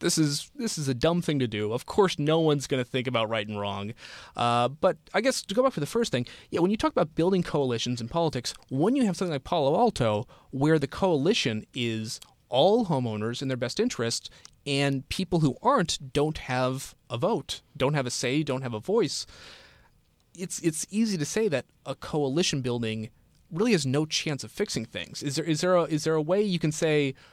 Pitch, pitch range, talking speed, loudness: 145 Hz, 125-175 Hz, 220 wpm, -27 LUFS